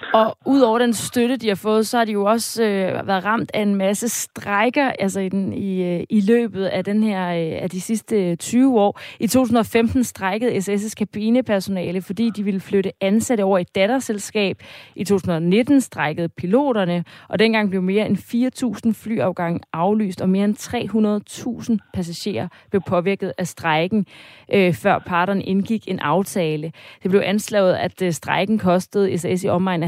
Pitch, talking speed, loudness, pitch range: 200 Hz, 165 wpm, -20 LUFS, 185-225 Hz